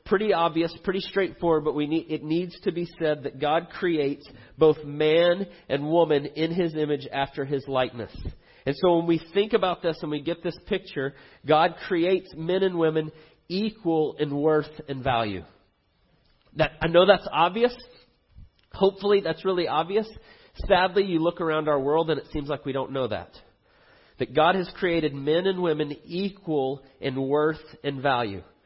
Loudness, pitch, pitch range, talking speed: -25 LUFS, 160 Hz, 145-175 Hz, 170 wpm